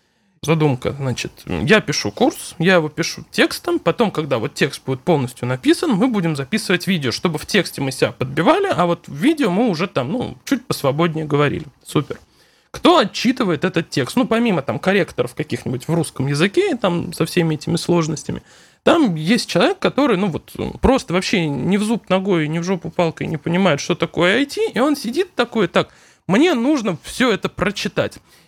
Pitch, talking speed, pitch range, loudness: 175 Hz, 180 wpm, 155-225 Hz, -18 LUFS